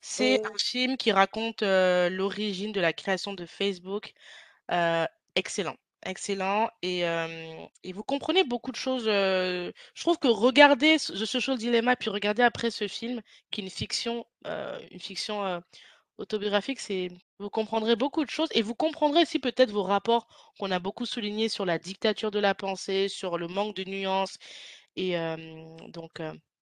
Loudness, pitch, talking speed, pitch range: -27 LUFS, 205 Hz, 175 wpm, 185-235 Hz